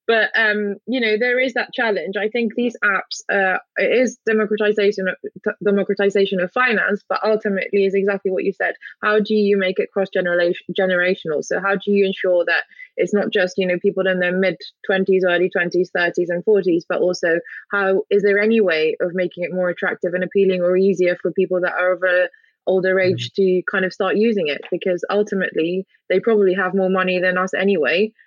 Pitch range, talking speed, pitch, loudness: 180-210 Hz, 200 wpm, 190 Hz, -19 LUFS